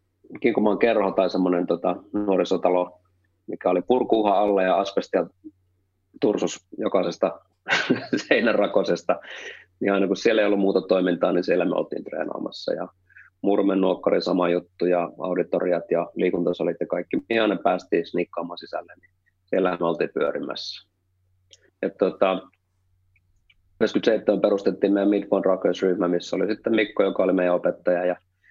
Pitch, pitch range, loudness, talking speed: 95 Hz, 90-95 Hz, -23 LUFS, 140 wpm